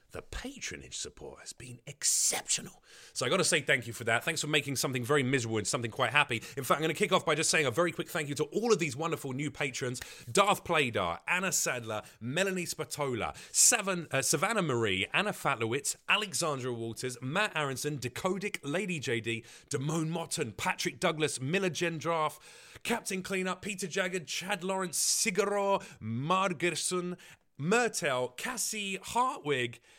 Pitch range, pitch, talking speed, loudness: 135-185 Hz, 160 Hz, 160 wpm, -31 LUFS